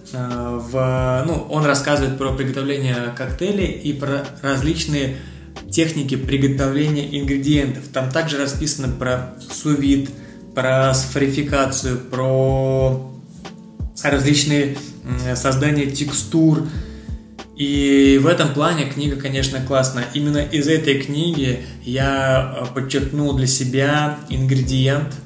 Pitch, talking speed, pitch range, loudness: 140 Hz, 95 wpm, 130-145 Hz, -19 LUFS